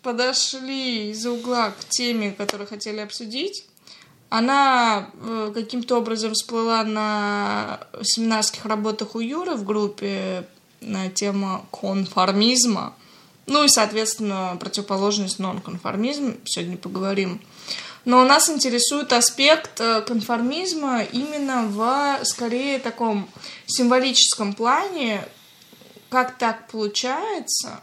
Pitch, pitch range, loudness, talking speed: 225 Hz, 205-255 Hz, -21 LUFS, 95 wpm